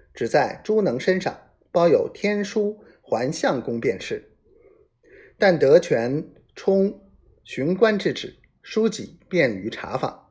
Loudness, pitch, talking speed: -22 LUFS, 215 Hz, 170 characters per minute